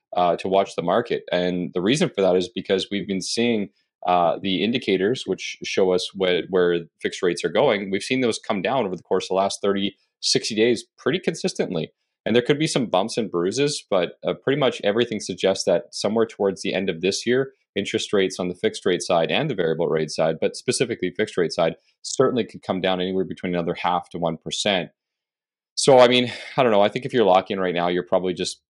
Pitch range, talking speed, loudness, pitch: 90-110 Hz, 225 wpm, -22 LUFS, 95 Hz